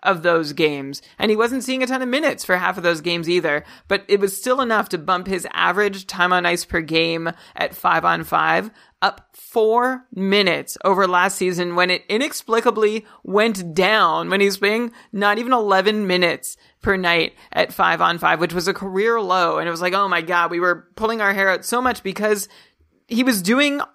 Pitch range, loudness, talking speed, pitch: 180-225 Hz, -19 LUFS, 210 wpm, 195 Hz